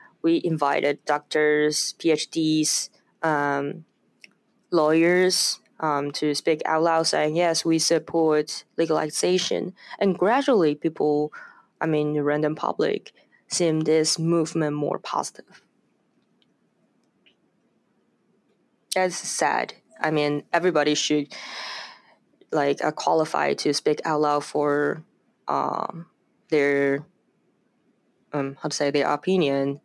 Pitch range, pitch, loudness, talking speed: 150-170 Hz, 155 Hz, -23 LUFS, 105 wpm